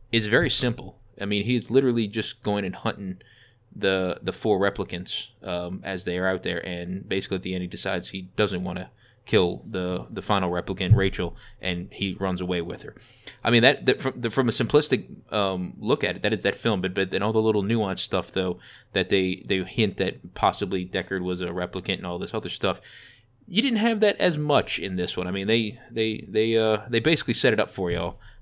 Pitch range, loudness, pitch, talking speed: 90-115 Hz, -25 LUFS, 100 Hz, 225 wpm